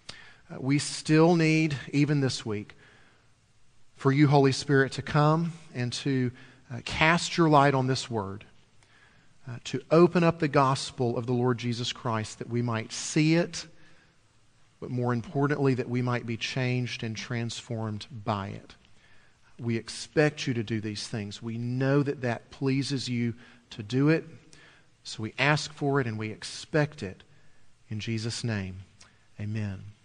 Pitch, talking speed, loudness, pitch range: 125 Hz, 160 wpm, -27 LUFS, 115-145 Hz